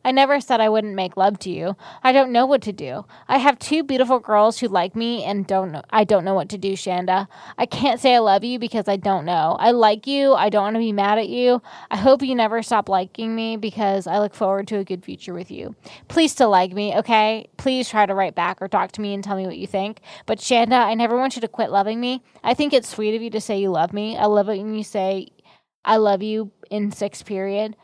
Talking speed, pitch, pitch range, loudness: 265 wpm, 215 Hz, 195-235 Hz, -20 LUFS